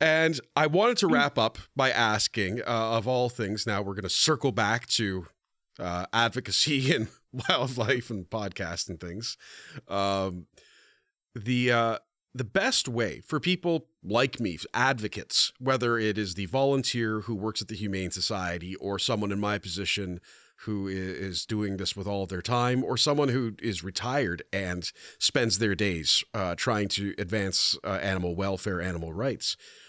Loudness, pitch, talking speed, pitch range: -28 LUFS, 105 Hz, 165 wpm, 95-125 Hz